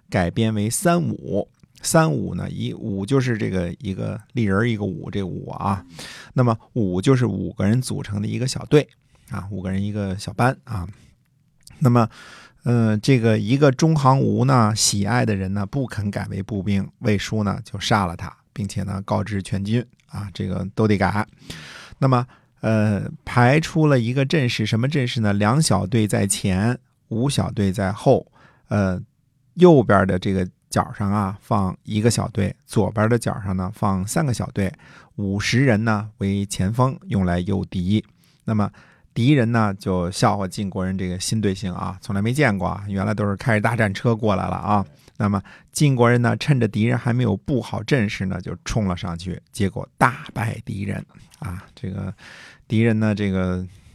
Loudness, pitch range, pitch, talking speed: -21 LUFS, 100-125 Hz, 105 Hz, 250 characters per minute